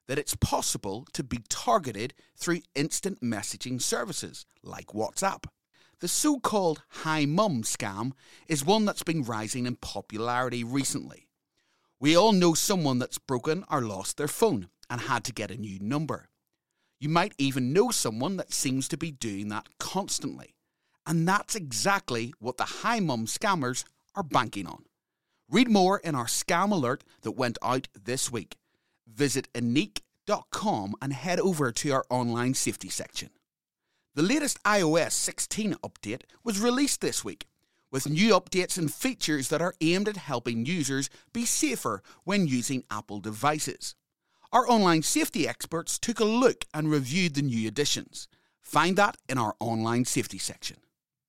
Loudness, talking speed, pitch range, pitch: -28 LUFS, 155 wpm, 120-180 Hz, 145 Hz